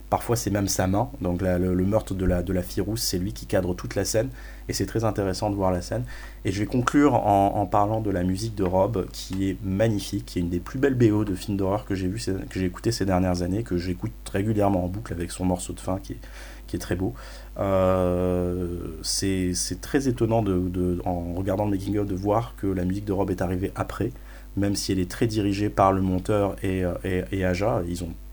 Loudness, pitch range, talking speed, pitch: -25 LUFS, 90-105 Hz, 250 wpm, 95 Hz